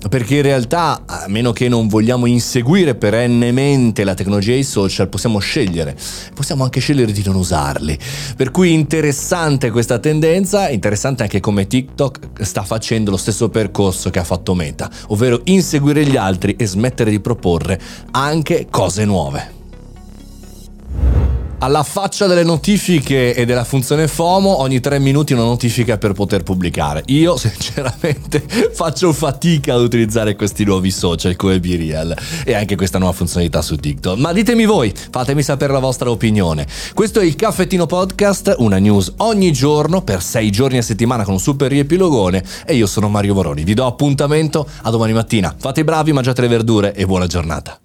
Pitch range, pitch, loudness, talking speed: 100-145 Hz, 120 Hz, -15 LUFS, 165 wpm